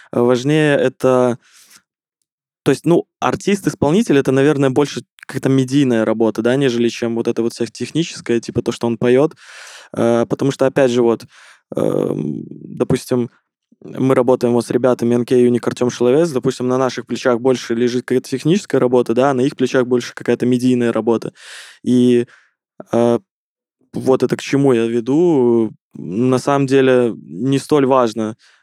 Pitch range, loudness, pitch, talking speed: 120-135 Hz, -16 LUFS, 125 Hz, 150 wpm